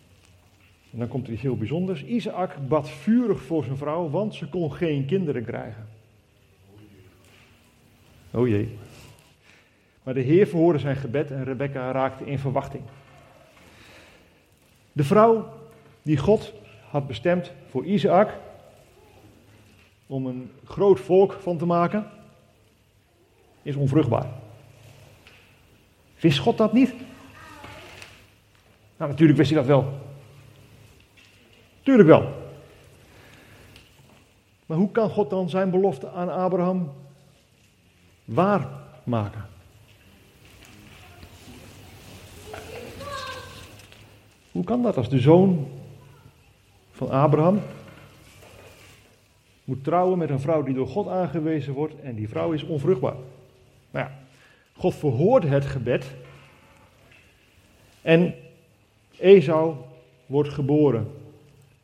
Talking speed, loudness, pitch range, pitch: 100 wpm, -23 LUFS, 105-155 Hz, 130 Hz